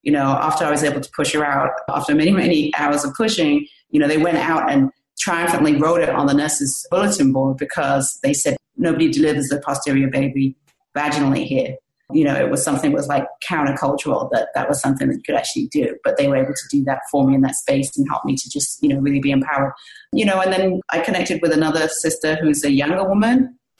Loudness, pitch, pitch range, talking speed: -18 LUFS, 150 Hz, 140-190 Hz, 235 wpm